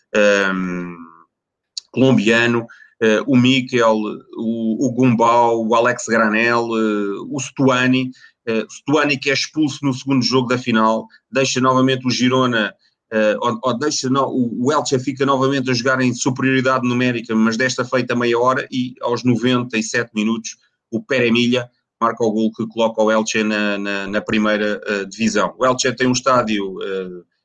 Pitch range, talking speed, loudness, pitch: 110-130 Hz, 155 wpm, -17 LUFS, 120 Hz